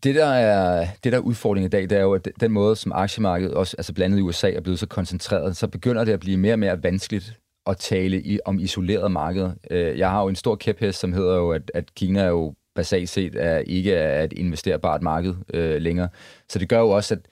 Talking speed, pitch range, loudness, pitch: 230 wpm, 90-105 Hz, -22 LUFS, 95 Hz